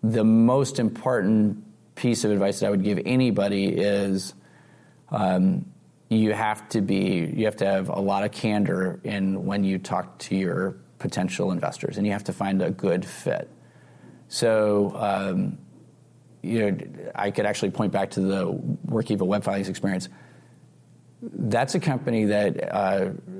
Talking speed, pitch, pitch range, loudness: 155 wpm, 105 Hz, 100-120 Hz, -25 LUFS